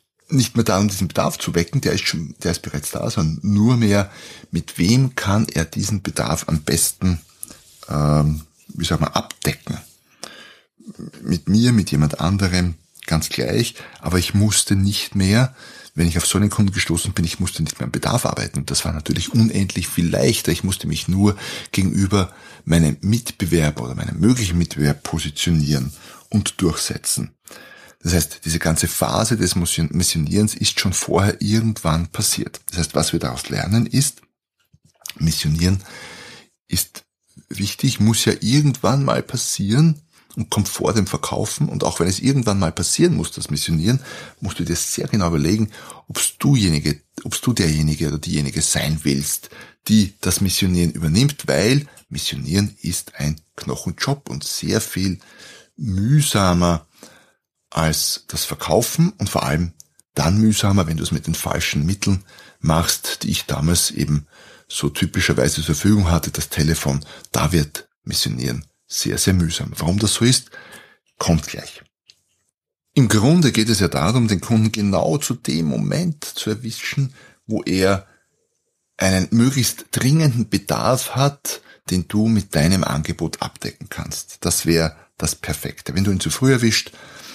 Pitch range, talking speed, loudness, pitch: 80-110 Hz, 155 wpm, -19 LUFS, 95 Hz